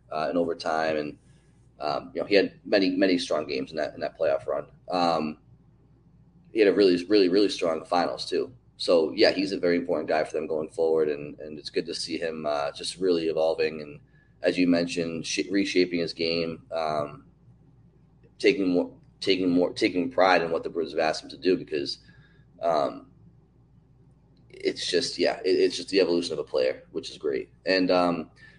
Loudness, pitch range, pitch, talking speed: -26 LUFS, 80-100 Hz, 85 Hz, 195 wpm